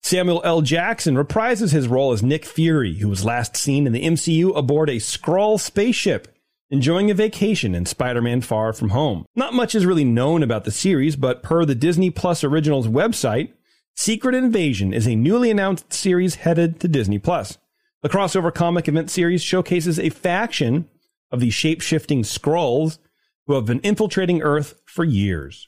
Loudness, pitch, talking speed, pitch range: -19 LUFS, 160 Hz, 170 wpm, 130-185 Hz